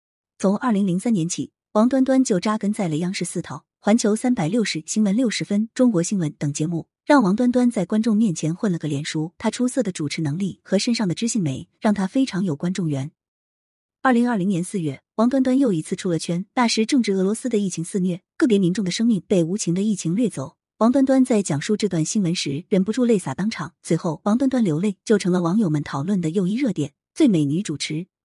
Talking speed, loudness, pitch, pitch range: 340 characters per minute, -21 LUFS, 195 Hz, 165-225 Hz